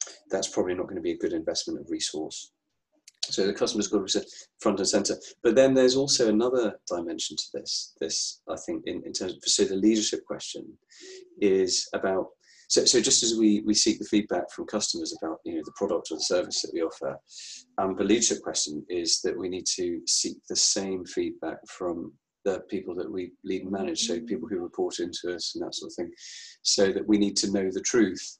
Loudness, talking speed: -27 LUFS, 220 wpm